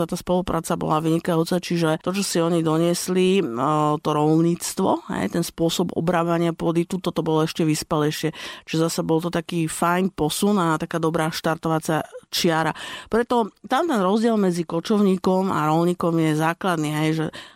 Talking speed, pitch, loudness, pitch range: 160 wpm, 170 Hz, -22 LUFS, 160-180 Hz